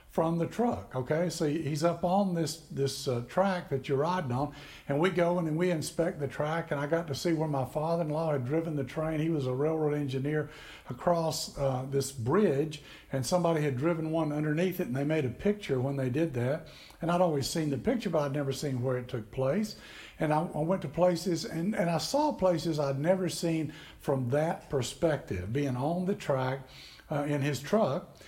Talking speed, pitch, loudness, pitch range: 220 wpm, 155 Hz, -31 LUFS, 140-170 Hz